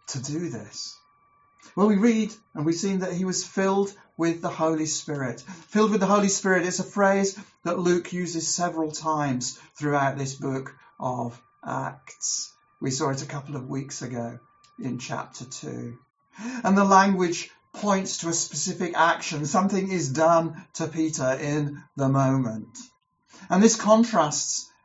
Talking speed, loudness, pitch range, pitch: 155 wpm, -25 LUFS, 145-195 Hz, 165 Hz